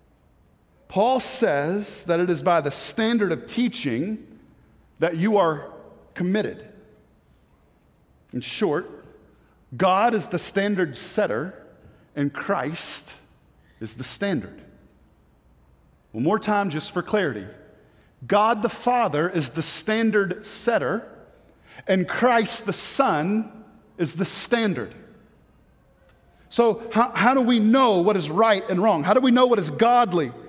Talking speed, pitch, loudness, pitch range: 125 wpm, 205 Hz, -22 LUFS, 170-230 Hz